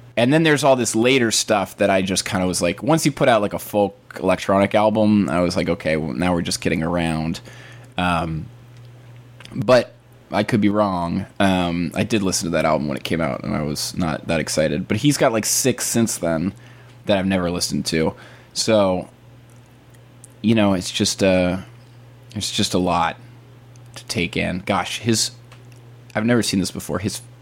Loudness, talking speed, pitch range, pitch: -20 LUFS, 195 wpm, 90-120 Hz, 105 Hz